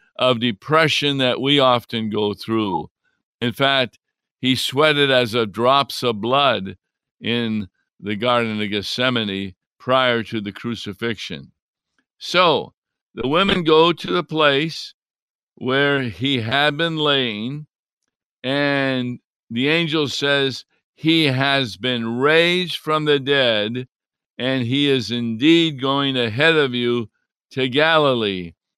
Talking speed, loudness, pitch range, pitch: 120 wpm, -19 LUFS, 115-145 Hz, 130 Hz